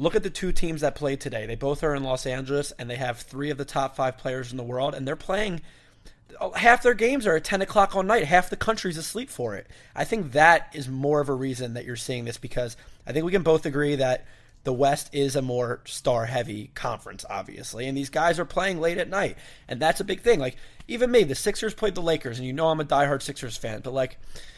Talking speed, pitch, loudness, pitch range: 255 wpm, 140 Hz, -25 LUFS, 130-175 Hz